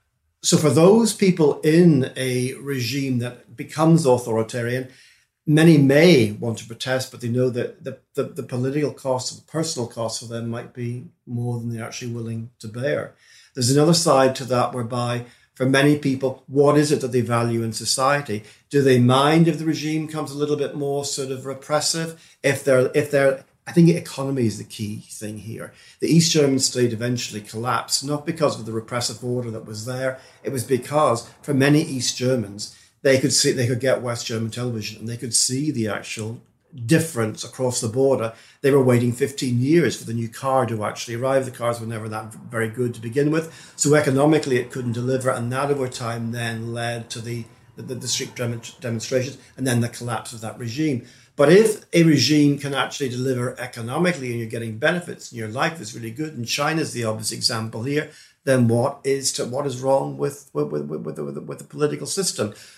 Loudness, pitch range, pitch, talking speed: -21 LUFS, 115-145 Hz, 130 Hz, 200 wpm